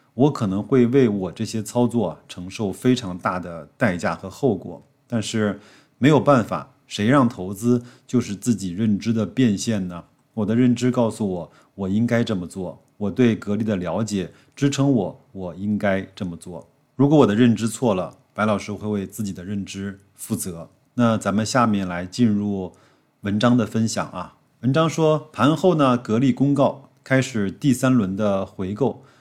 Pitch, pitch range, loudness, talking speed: 110 Hz, 100-130 Hz, -21 LUFS, 250 characters per minute